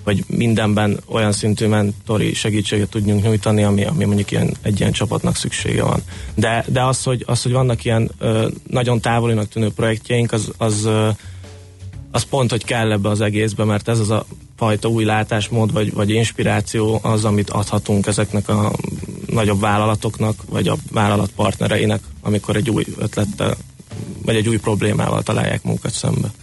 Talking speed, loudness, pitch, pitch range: 155 wpm, -18 LUFS, 110 Hz, 105-115 Hz